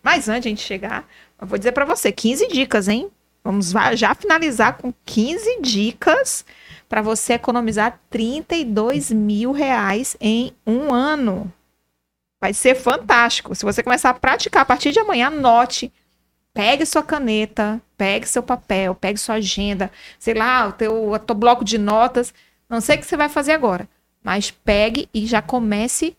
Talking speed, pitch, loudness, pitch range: 165 wpm, 235 Hz, -18 LUFS, 215-255 Hz